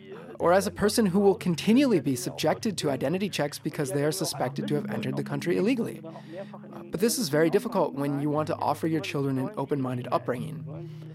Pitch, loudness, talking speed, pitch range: 155 Hz, -27 LUFS, 205 wpm, 145-190 Hz